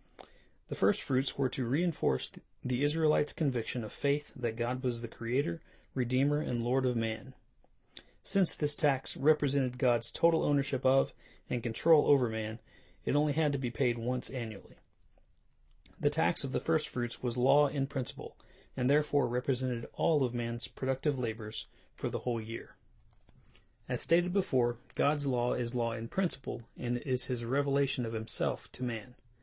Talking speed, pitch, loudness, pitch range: 165 wpm, 125 Hz, -32 LUFS, 120-140 Hz